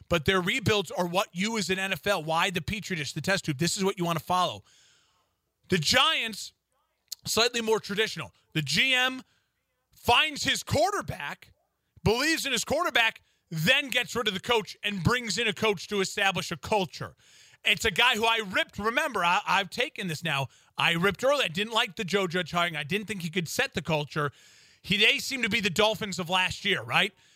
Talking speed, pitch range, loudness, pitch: 205 wpm, 175-225 Hz, -26 LUFS, 200 Hz